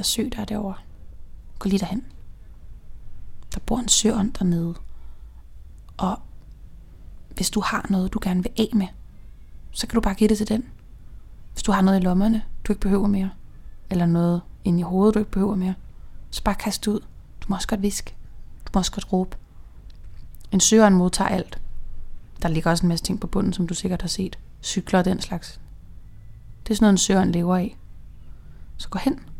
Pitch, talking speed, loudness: 185 Hz, 200 wpm, -23 LUFS